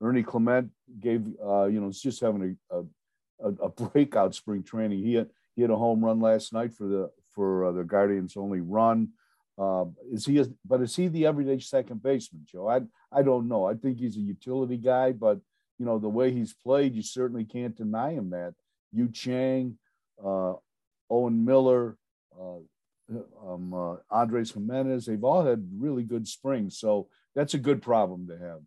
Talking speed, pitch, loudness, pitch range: 190 wpm, 115 Hz, -28 LUFS, 100-130 Hz